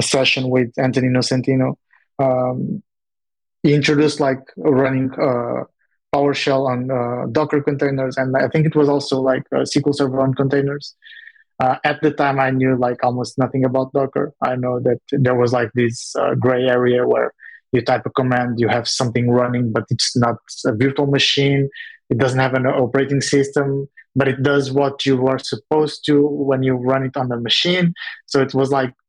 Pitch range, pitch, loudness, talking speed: 125-140 Hz, 135 Hz, -18 LUFS, 180 wpm